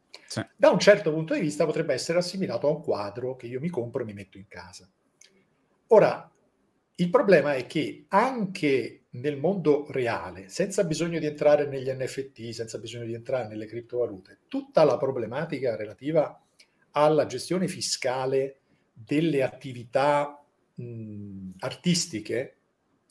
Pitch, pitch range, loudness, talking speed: 140 Hz, 120-165 Hz, -26 LUFS, 140 wpm